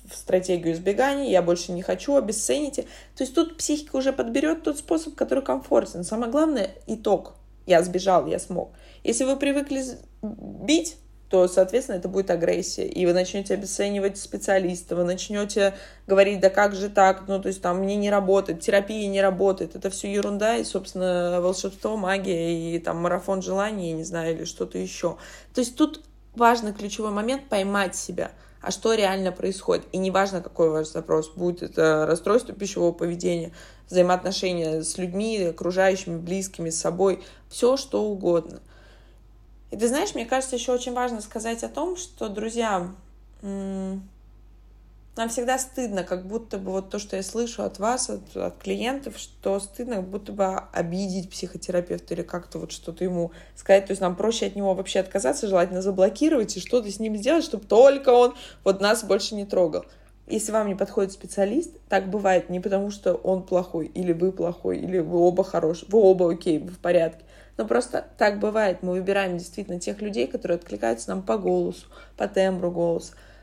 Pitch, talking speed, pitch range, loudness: 195 Hz, 175 wpm, 175-220 Hz, -24 LUFS